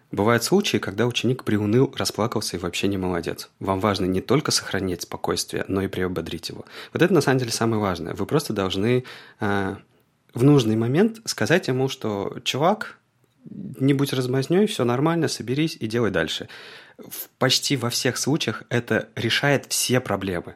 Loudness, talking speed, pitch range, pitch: -23 LUFS, 160 wpm, 100-135 Hz, 120 Hz